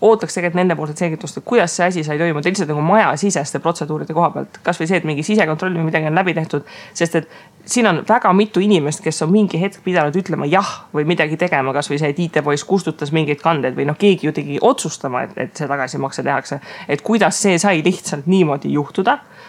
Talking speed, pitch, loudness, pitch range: 210 wpm, 170 Hz, -17 LUFS, 155-190 Hz